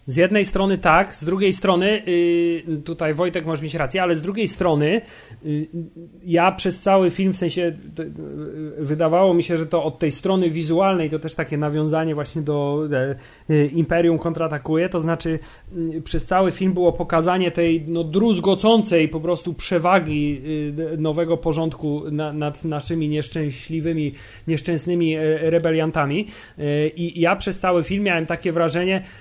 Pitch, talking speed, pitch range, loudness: 165 Hz, 140 wpm, 155-180 Hz, -21 LUFS